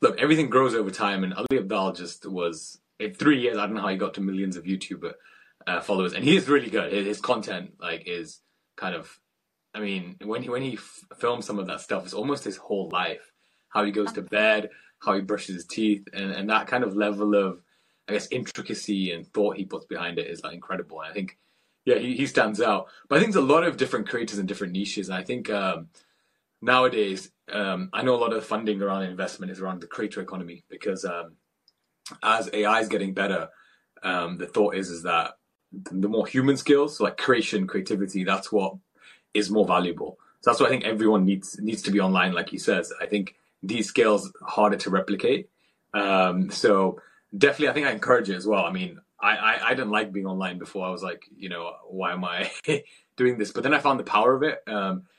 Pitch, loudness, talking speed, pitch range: 100 Hz, -25 LUFS, 225 wpm, 95-110 Hz